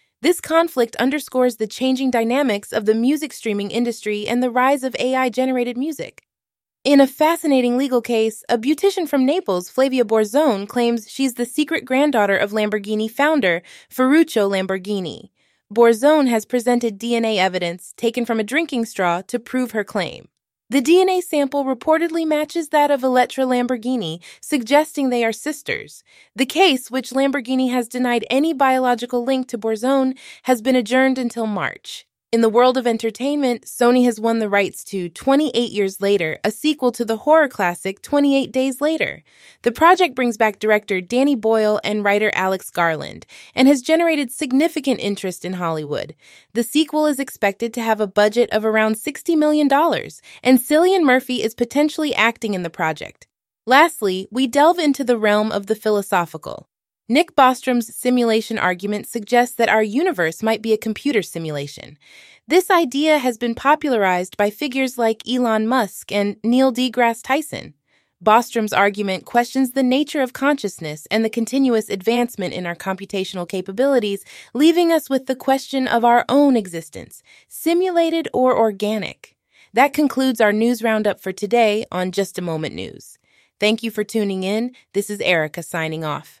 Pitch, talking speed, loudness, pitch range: 240 Hz, 160 wpm, -19 LUFS, 210-275 Hz